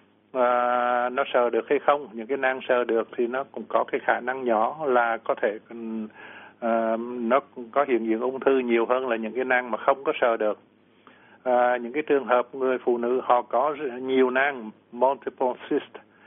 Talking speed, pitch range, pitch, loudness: 200 wpm, 115-130 Hz, 125 Hz, -25 LUFS